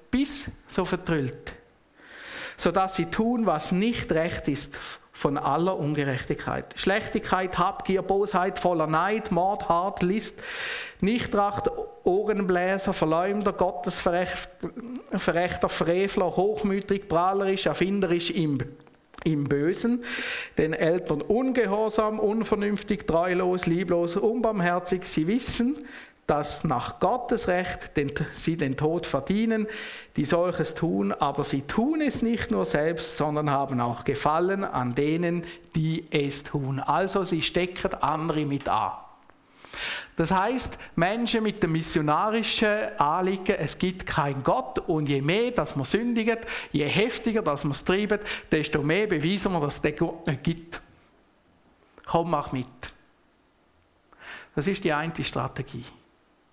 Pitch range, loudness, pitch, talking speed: 155-205 Hz, -26 LUFS, 180 Hz, 120 wpm